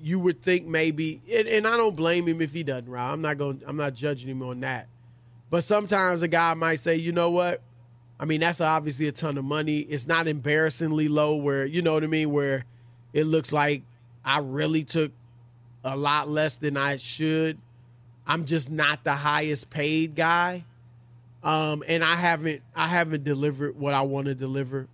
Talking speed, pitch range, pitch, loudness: 195 wpm, 135-160 Hz, 150 Hz, -25 LUFS